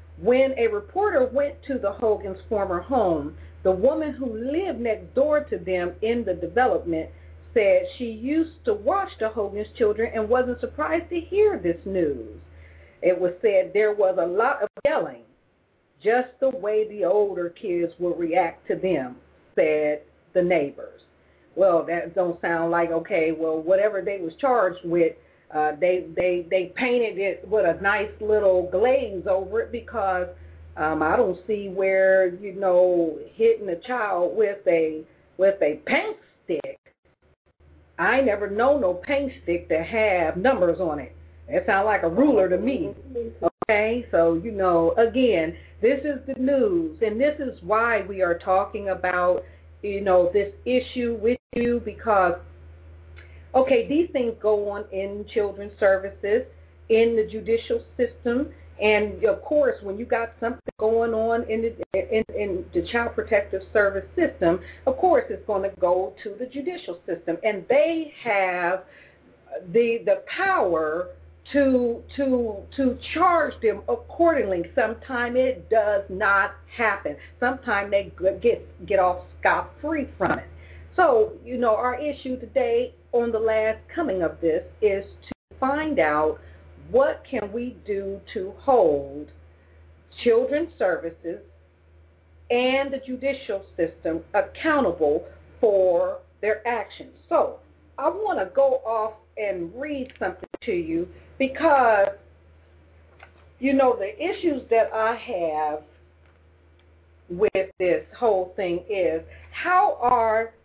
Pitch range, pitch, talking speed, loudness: 175-255 Hz, 210 Hz, 145 wpm, -24 LUFS